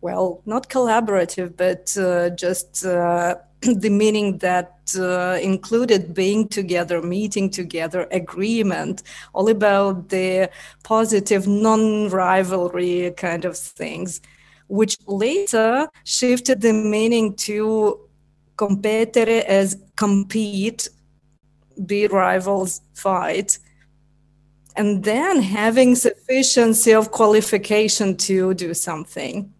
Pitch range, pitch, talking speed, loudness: 180-215 Hz, 195 Hz, 95 wpm, -19 LUFS